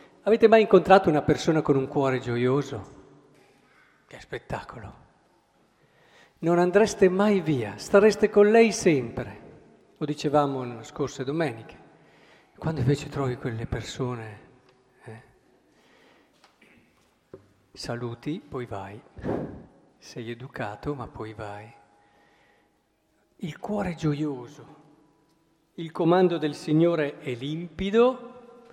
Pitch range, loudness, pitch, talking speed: 125-170 Hz, -24 LUFS, 145 Hz, 100 wpm